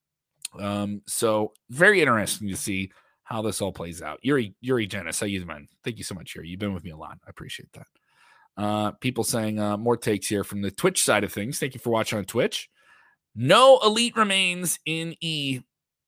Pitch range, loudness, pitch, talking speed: 100-135 Hz, -24 LUFS, 105 Hz, 205 wpm